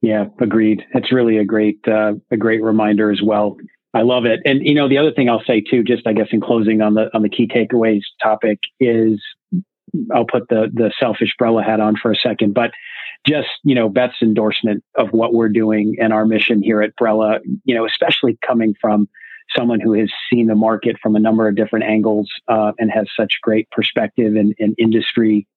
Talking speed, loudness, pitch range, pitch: 210 wpm, -16 LUFS, 110-115 Hz, 110 Hz